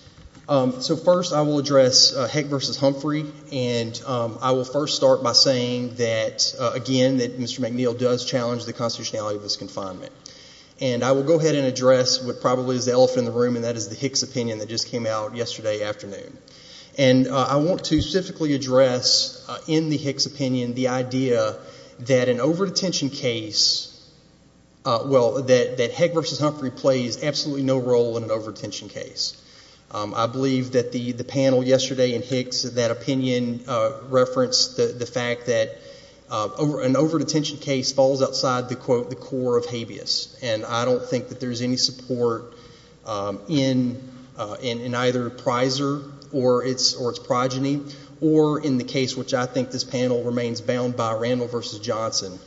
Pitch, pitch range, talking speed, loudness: 130 Hz, 120-140 Hz, 180 wpm, -22 LUFS